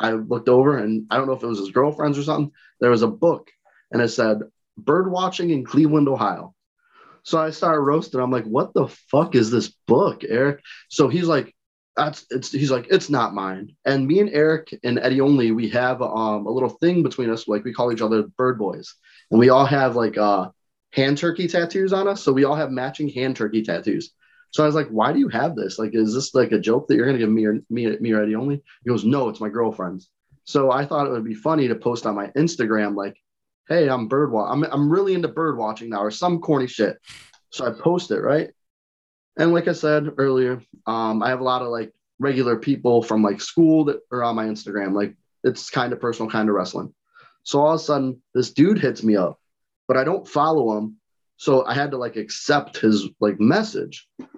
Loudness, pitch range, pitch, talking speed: -21 LUFS, 110-150 Hz, 130 Hz, 230 wpm